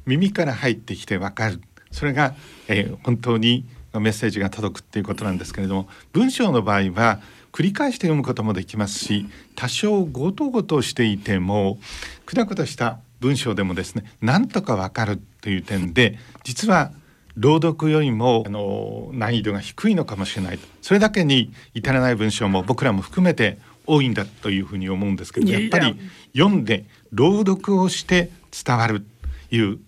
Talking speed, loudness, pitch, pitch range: 350 characters per minute, -21 LUFS, 115 Hz, 100-150 Hz